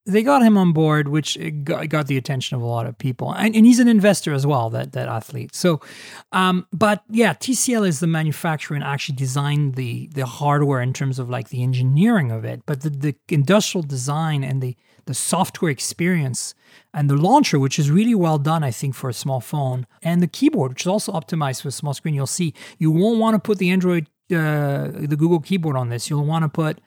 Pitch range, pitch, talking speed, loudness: 135-180 Hz, 150 Hz, 225 wpm, -20 LUFS